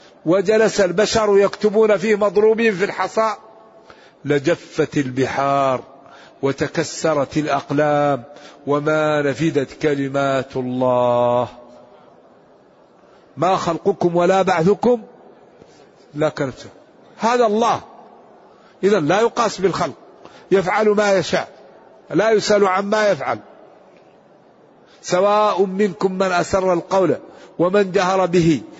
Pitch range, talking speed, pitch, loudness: 145-205 Hz, 90 wpm, 180 Hz, -18 LUFS